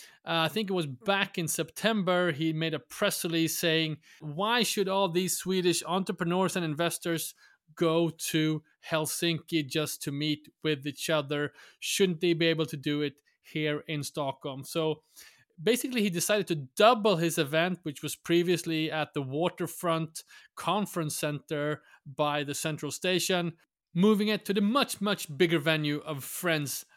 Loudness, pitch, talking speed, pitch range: -29 LUFS, 165 Hz, 160 wpm, 155-180 Hz